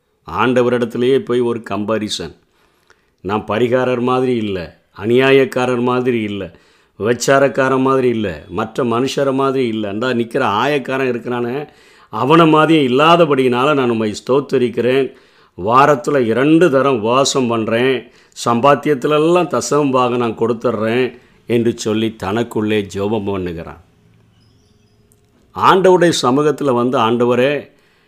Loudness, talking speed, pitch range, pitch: -15 LUFS, 100 wpm, 110-135 Hz, 125 Hz